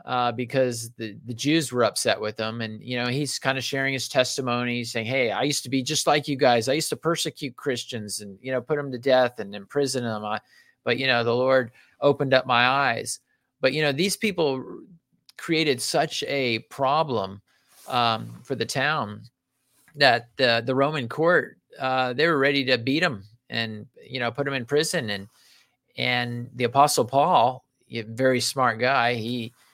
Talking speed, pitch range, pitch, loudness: 190 wpm, 120-140 Hz, 130 Hz, -24 LUFS